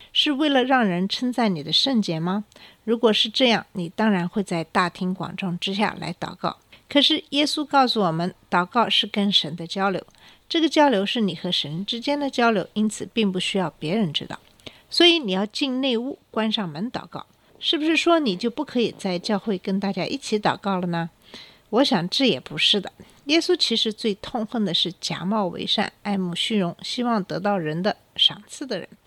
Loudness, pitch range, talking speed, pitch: -22 LUFS, 185-245 Hz, 285 characters per minute, 210 Hz